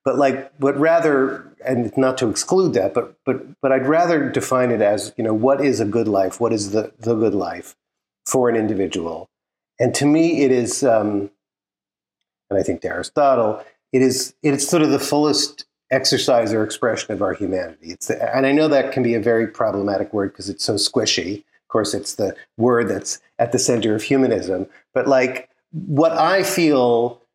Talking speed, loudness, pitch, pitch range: 200 wpm, -19 LUFS, 130 Hz, 115-140 Hz